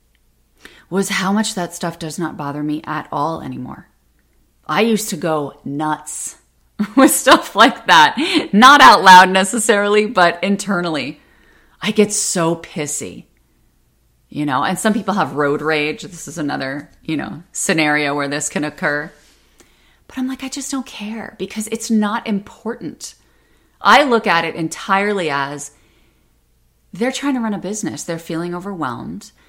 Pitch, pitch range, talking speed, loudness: 170 Hz, 150-210 Hz, 155 wpm, -16 LUFS